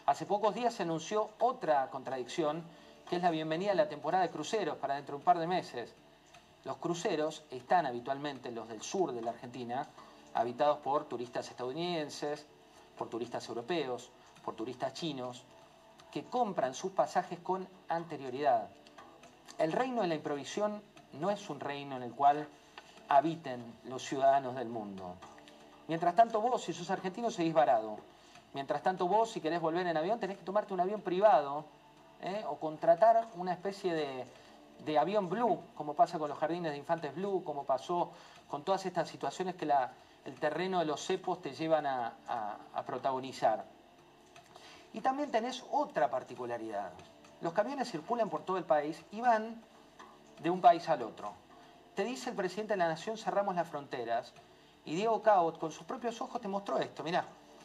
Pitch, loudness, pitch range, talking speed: 165 Hz, -34 LUFS, 140-200 Hz, 170 wpm